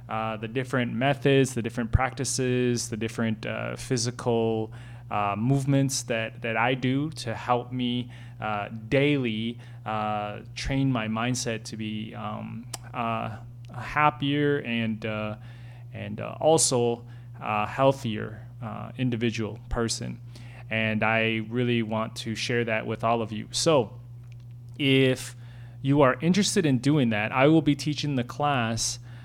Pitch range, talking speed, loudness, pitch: 110-130 Hz, 135 wpm, -26 LUFS, 120 Hz